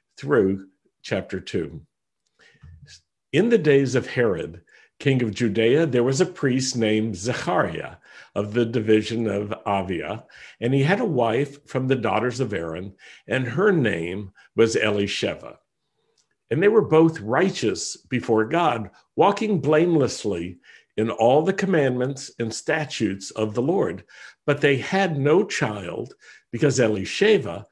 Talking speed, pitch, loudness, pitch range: 135 wpm, 125 Hz, -22 LUFS, 110-150 Hz